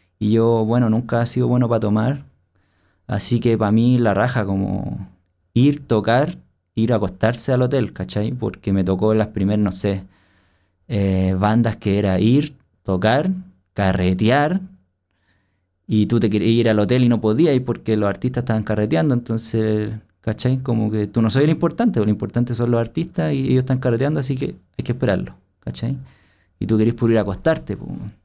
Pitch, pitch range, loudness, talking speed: 110 Hz, 100-125 Hz, -19 LUFS, 185 wpm